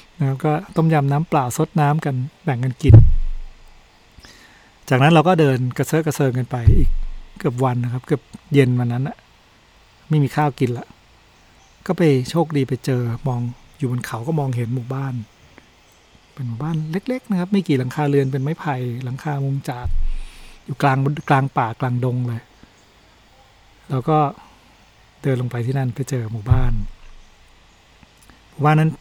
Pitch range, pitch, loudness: 115-145 Hz, 130 Hz, -20 LUFS